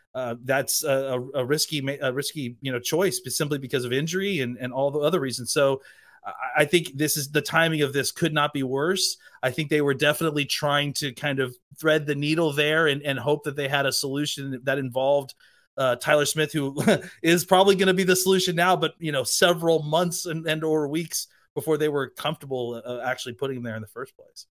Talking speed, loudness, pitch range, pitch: 225 wpm, -24 LUFS, 135-160 Hz, 150 Hz